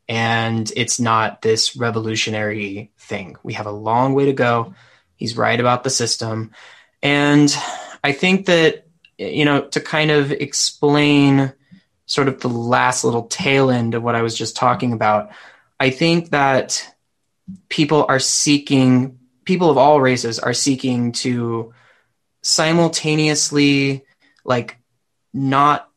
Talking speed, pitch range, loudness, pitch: 135 wpm, 115-145 Hz, -17 LUFS, 130 Hz